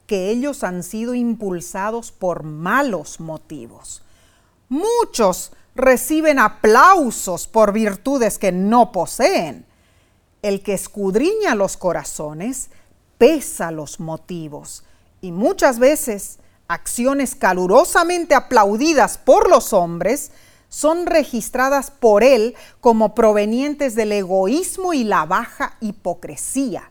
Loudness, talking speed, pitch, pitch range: -17 LUFS, 100 wpm, 215 Hz, 180-270 Hz